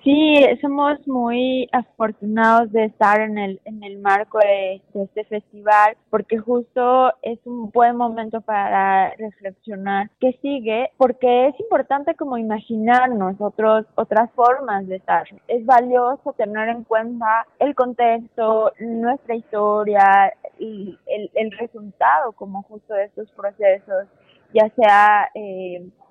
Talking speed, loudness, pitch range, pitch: 125 wpm, -18 LUFS, 205-245 Hz, 225 Hz